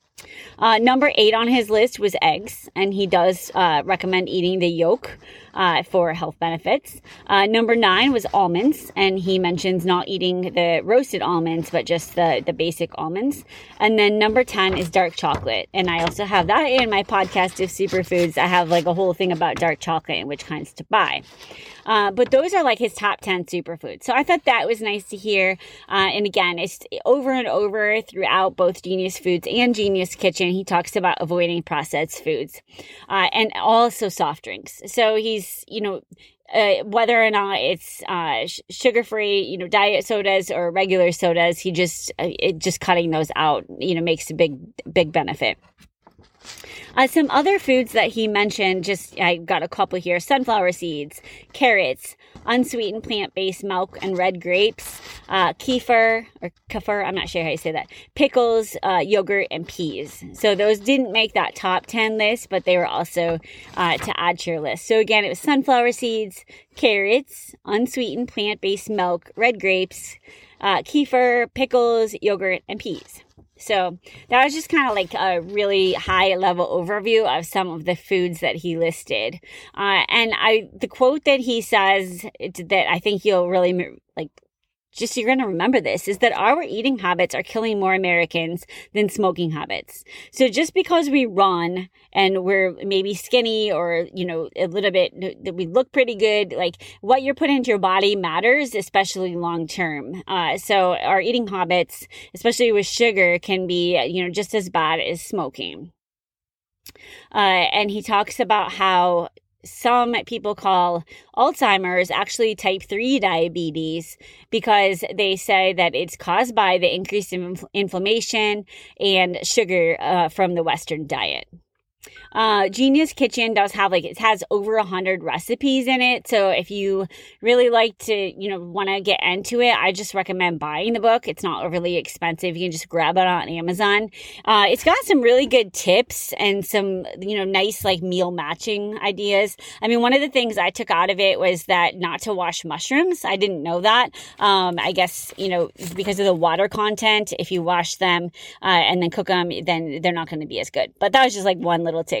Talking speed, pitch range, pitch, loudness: 185 wpm, 180-225 Hz, 195 Hz, -20 LUFS